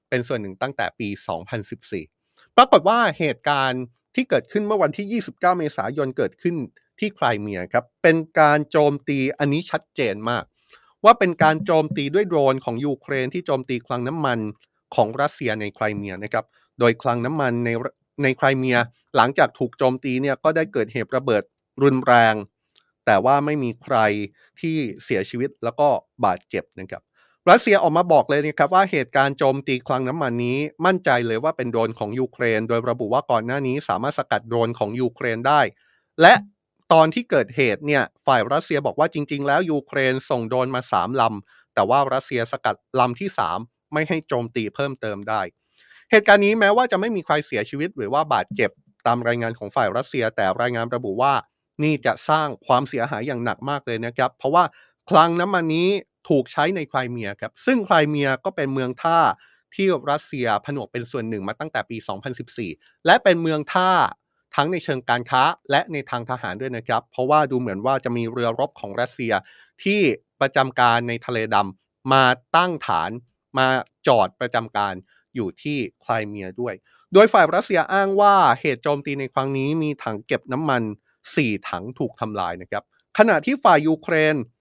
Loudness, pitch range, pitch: -21 LUFS, 120-155 Hz, 135 Hz